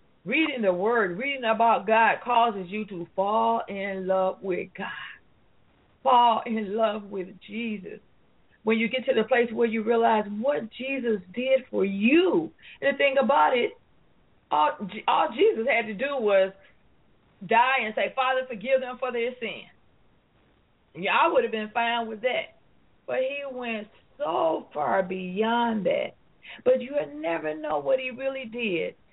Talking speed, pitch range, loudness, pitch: 160 wpm, 205-260 Hz, -25 LUFS, 230 Hz